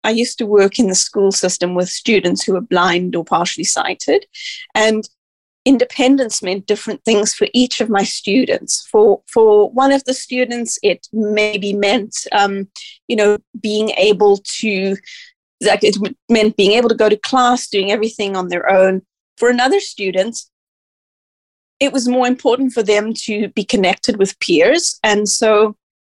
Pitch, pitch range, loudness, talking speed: 215 Hz, 200-250 Hz, -15 LUFS, 160 wpm